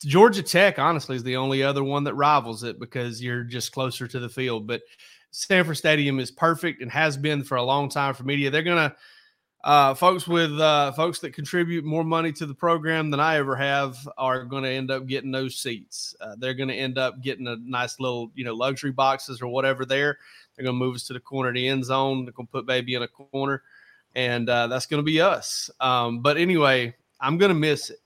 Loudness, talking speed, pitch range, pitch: -24 LUFS, 235 wpm, 130-155 Hz, 135 Hz